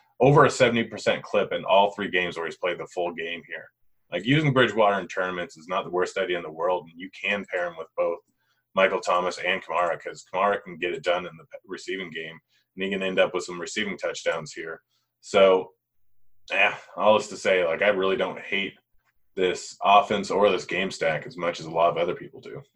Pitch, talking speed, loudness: 100 Hz, 225 wpm, -25 LUFS